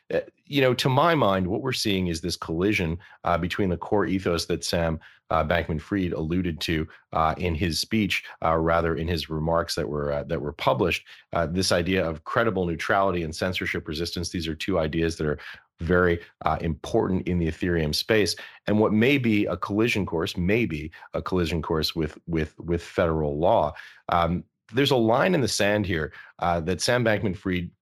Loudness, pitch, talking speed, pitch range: -25 LUFS, 85 Hz, 190 wpm, 80-100 Hz